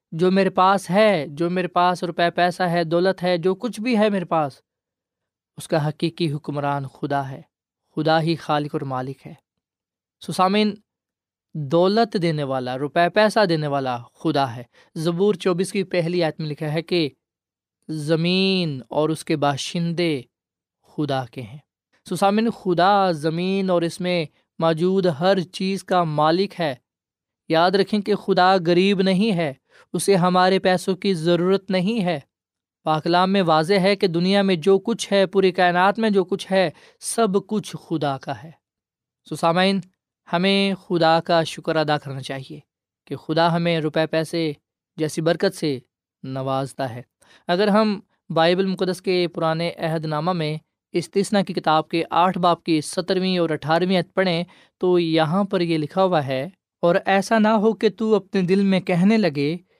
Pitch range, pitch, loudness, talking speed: 155-190 Hz, 175 Hz, -21 LUFS, 165 wpm